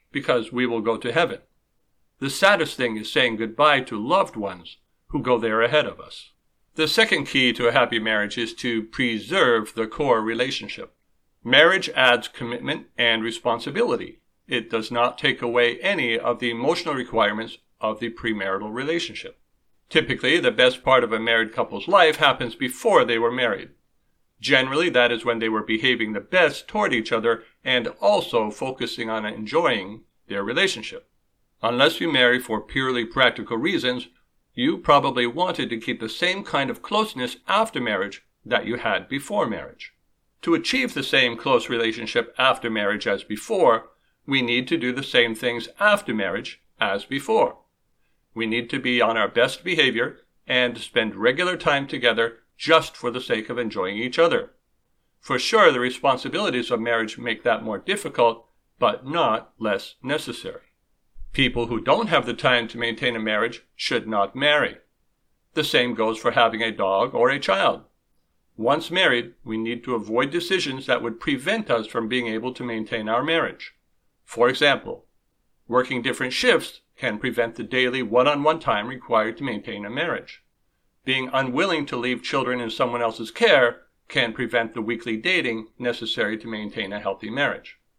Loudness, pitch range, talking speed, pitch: -22 LUFS, 115-130 Hz, 165 wpm, 120 Hz